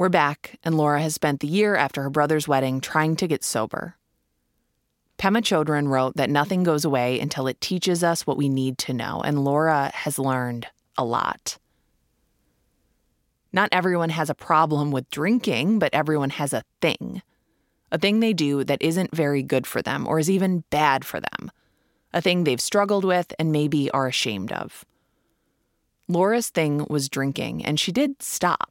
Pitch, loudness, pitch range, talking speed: 150 Hz, -23 LUFS, 140-180 Hz, 175 wpm